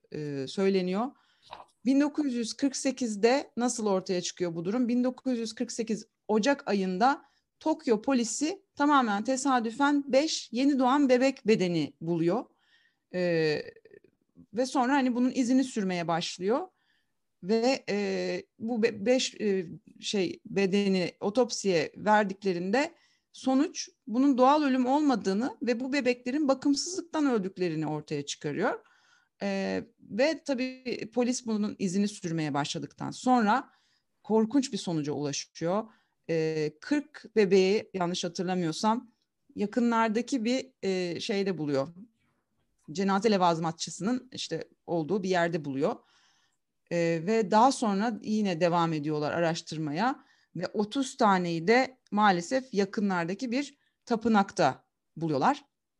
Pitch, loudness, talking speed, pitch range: 220 Hz, -29 LUFS, 105 wpm, 180-260 Hz